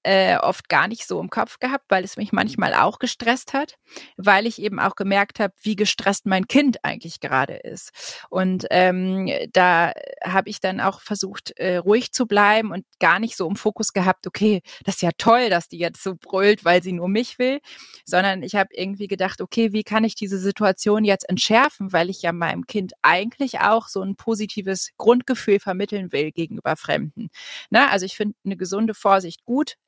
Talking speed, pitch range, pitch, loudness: 195 wpm, 190-225 Hz, 200 Hz, -21 LUFS